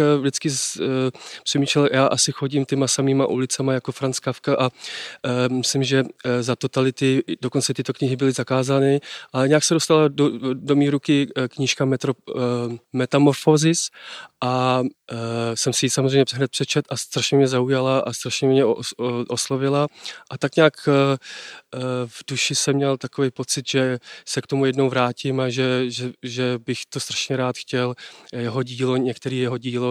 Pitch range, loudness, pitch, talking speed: 125-140 Hz, -21 LUFS, 135 Hz, 175 wpm